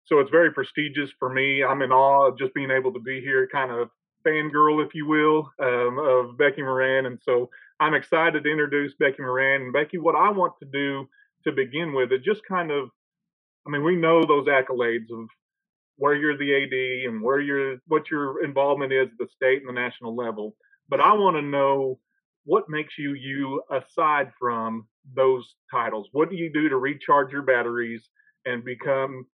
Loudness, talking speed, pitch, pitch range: -23 LUFS, 195 wpm, 135 Hz, 130-150 Hz